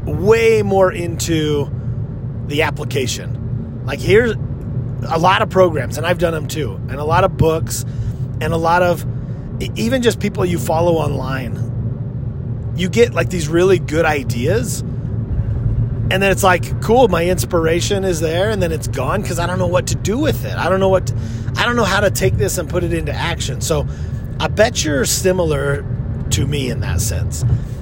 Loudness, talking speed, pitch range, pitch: -17 LUFS, 190 wpm, 120-155 Hz, 130 Hz